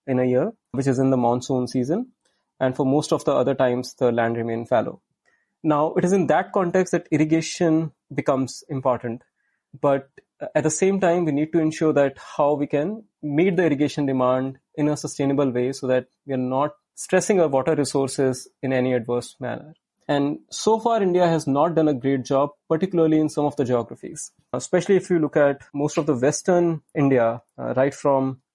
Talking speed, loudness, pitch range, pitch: 195 wpm, -22 LUFS, 130-165 Hz, 145 Hz